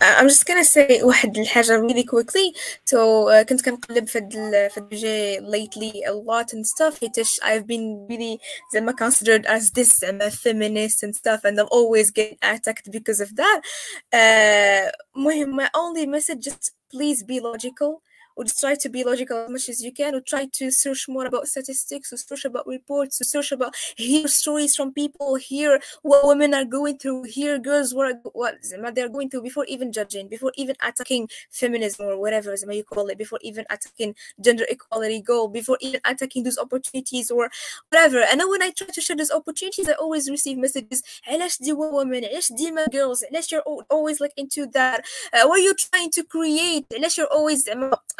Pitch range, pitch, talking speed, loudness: 225-290 Hz, 260 Hz, 180 wpm, -20 LUFS